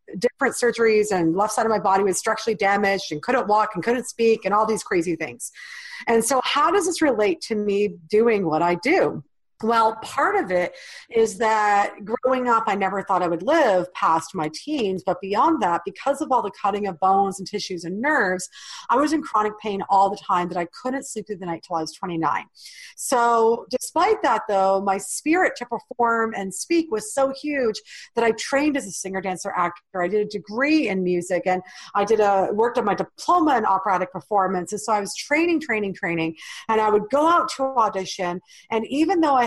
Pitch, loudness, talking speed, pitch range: 210 Hz, -22 LUFS, 215 wpm, 190-250 Hz